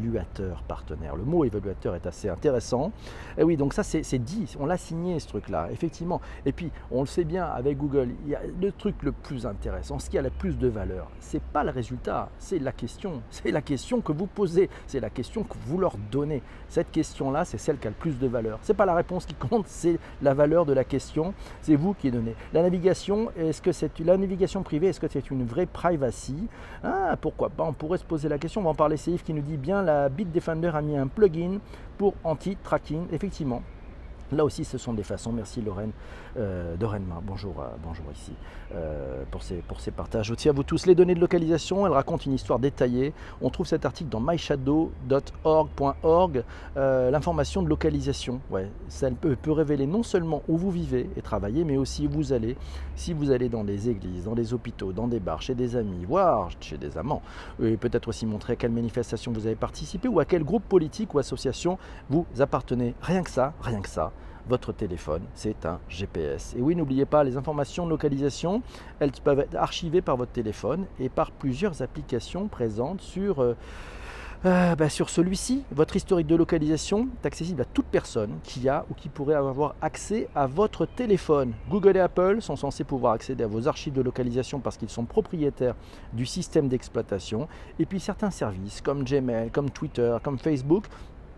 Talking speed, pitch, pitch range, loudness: 210 wpm, 140 Hz, 115-170 Hz, -27 LUFS